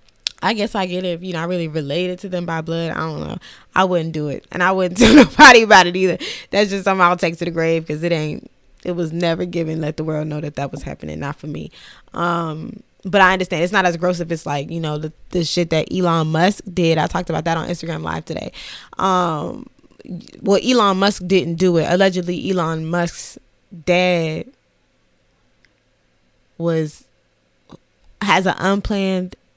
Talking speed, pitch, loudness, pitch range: 200 wpm, 175 Hz, -17 LUFS, 165-185 Hz